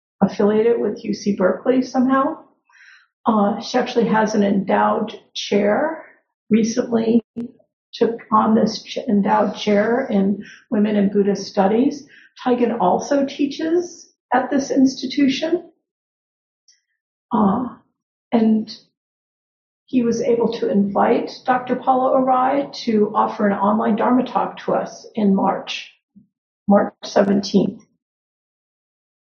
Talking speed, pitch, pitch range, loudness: 105 wpm, 230 Hz, 210-260 Hz, -19 LUFS